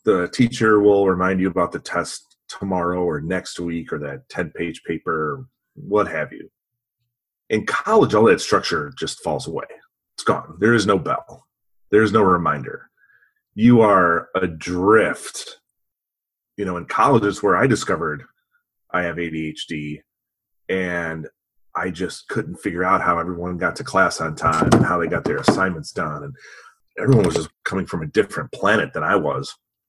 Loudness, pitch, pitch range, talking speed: -20 LUFS, 95 Hz, 85-120 Hz, 165 wpm